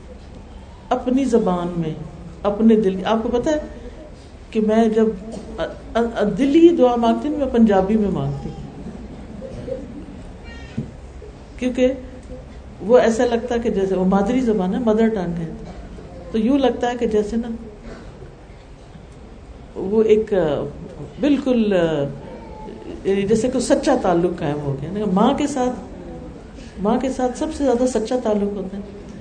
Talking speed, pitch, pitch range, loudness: 135 wpm, 220 Hz, 185-245 Hz, -19 LUFS